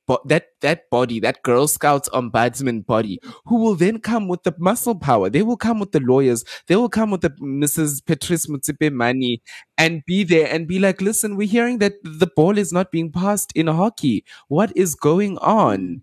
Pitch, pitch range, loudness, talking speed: 165 Hz, 140-200 Hz, -19 LUFS, 200 wpm